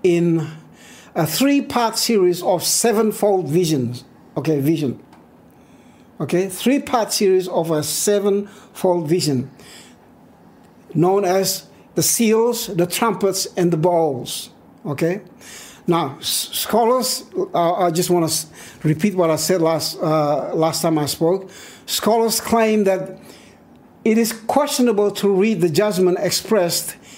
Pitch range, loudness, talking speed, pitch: 165-220 Hz, -18 LUFS, 125 wpm, 185 Hz